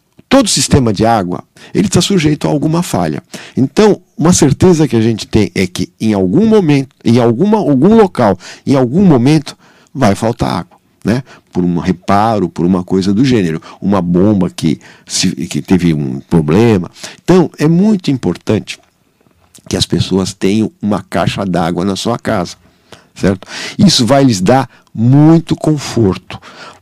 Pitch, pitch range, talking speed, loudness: 125 Hz, 95-160 Hz, 155 wpm, -12 LUFS